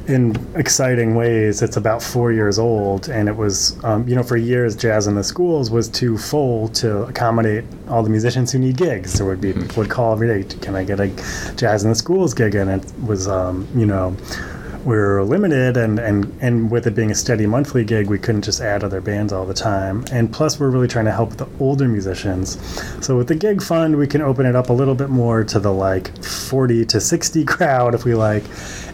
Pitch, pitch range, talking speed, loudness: 115 Hz, 100-125 Hz, 225 wpm, -18 LUFS